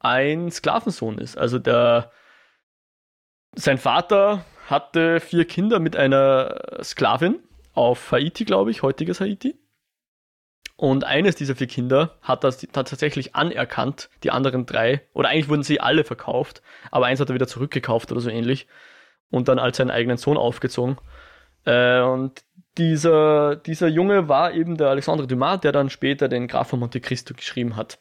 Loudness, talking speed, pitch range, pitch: -21 LUFS, 155 wpm, 125-160 Hz, 135 Hz